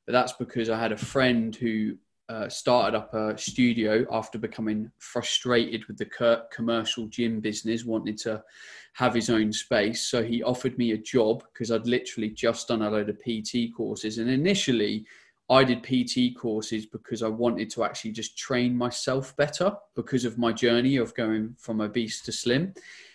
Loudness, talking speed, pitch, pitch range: -27 LUFS, 175 wpm, 115 Hz, 110-125 Hz